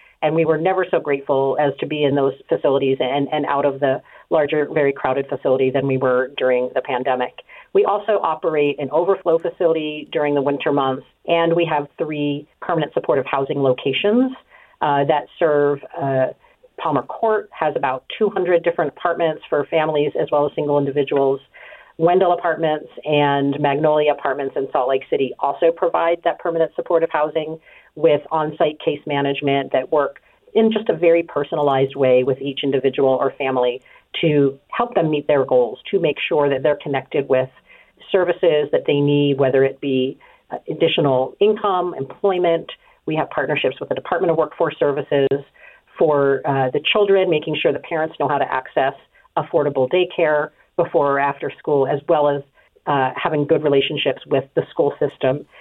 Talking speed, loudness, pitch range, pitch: 170 wpm, -19 LUFS, 140-170 Hz, 145 Hz